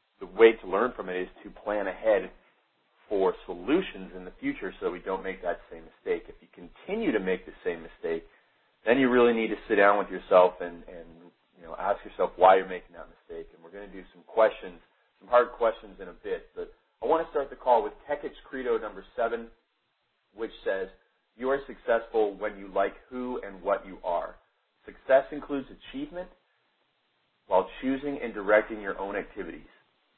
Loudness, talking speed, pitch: -28 LUFS, 195 wpm, 120 Hz